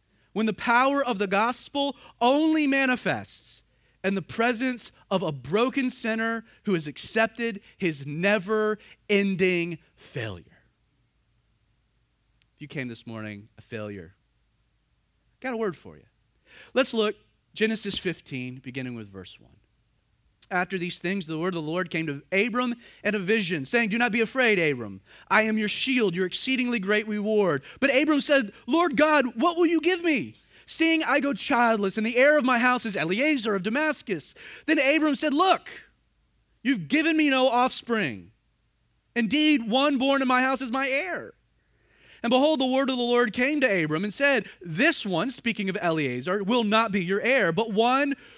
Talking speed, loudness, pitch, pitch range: 170 wpm, -24 LUFS, 220 Hz, 170-260 Hz